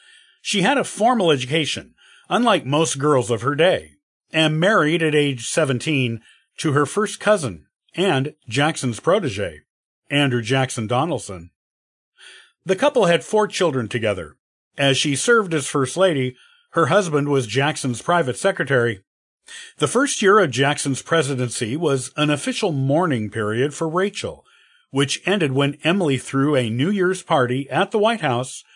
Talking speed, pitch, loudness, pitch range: 145 wpm, 145 Hz, -20 LUFS, 130-170 Hz